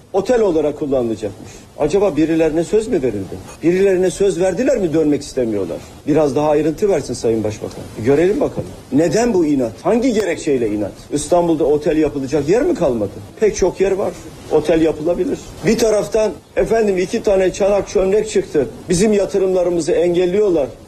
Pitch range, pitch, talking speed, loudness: 155-200 Hz, 180 Hz, 150 wpm, -17 LUFS